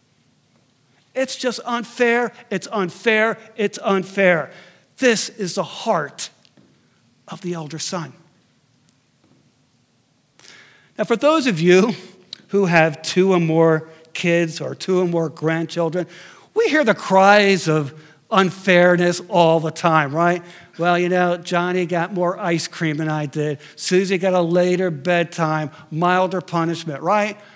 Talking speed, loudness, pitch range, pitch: 130 wpm, -19 LUFS, 165-195 Hz, 180 Hz